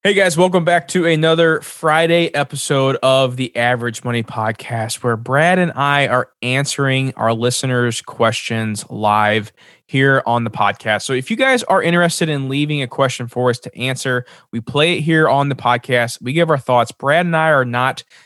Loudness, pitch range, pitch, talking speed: -16 LUFS, 120-155 Hz, 130 Hz, 185 wpm